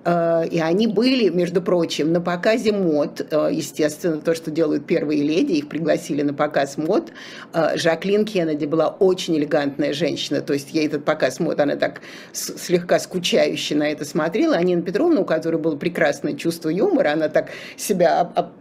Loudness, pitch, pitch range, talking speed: -20 LUFS, 165 Hz, 150-180 Hz, 160 wpm